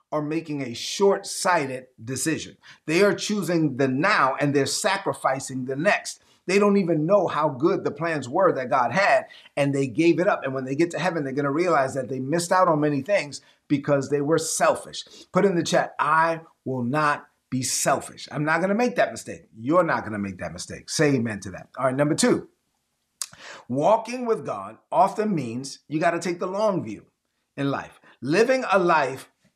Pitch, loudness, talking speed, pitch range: 150 Hz, -23 LUFS, 200 wpm, 135-185 Hz